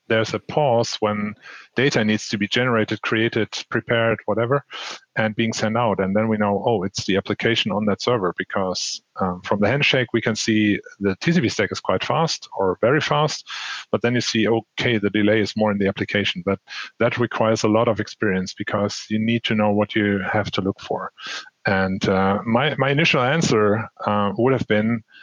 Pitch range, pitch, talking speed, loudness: 105-120 Hz, 110 Hz, 200 wpm, -21 LUFS